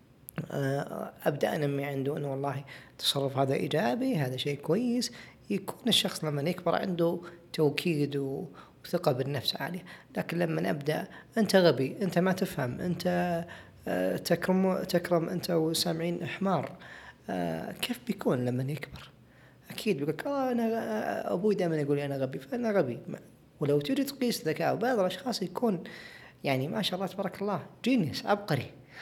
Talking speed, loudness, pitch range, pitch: 130 wpm, -30 LUFS, 140-195 Hz, 170 Hz